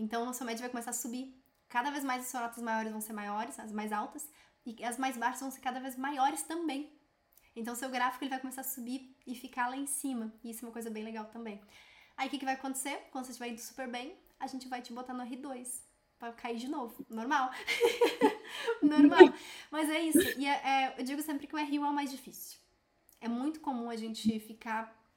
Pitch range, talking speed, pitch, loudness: 235-280 Hz, 235 wpm, 255 Hz, -33 LUFS